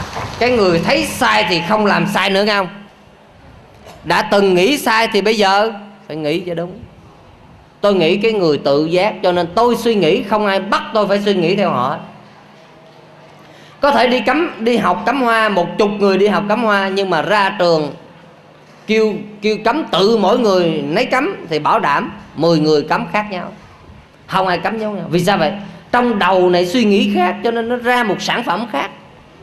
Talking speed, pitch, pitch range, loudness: 200 wpm, 200 Hz, 175-220 Hz, -15 LUFS